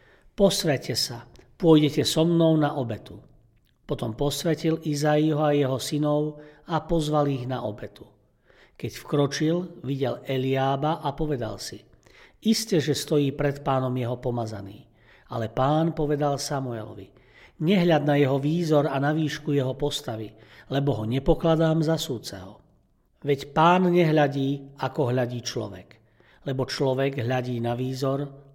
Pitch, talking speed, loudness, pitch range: 140 Hz, 130 wpm, -25 LUFS, 125-150 Hz